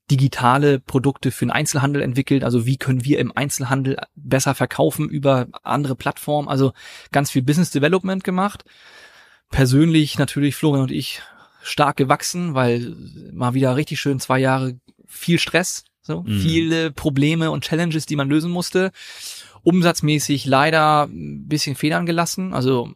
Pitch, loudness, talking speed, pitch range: 145 Hz, -19 LUFS, 145 wpm, 135-160 Hz